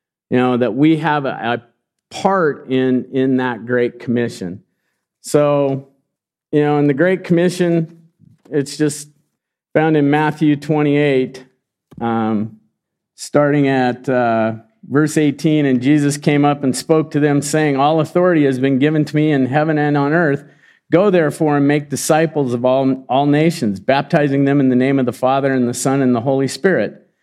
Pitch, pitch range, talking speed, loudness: 140 Hz, 130-150 Hz, 170 wpm, -16 LUFS